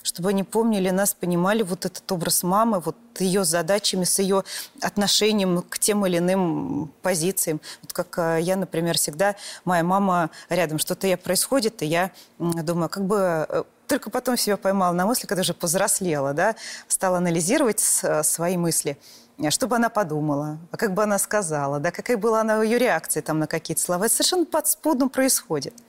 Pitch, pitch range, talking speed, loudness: 185 Hz, 170-210 Hz, 165 wpm, -22 LUFS